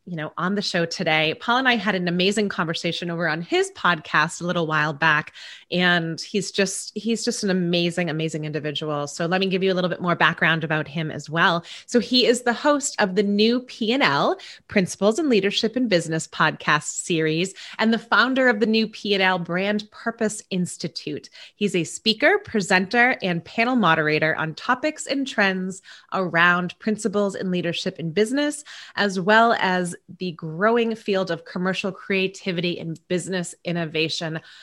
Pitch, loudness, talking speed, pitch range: 185 Hz, -22 LUFS, 180 wpm, 170-220 Hz